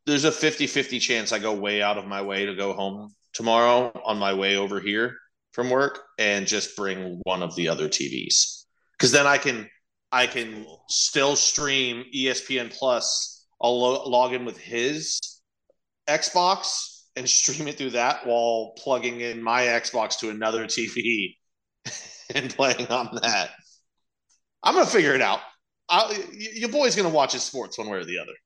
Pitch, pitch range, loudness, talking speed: 120 Hz, 110-140 Hz, -23 LUFS, 175 wpm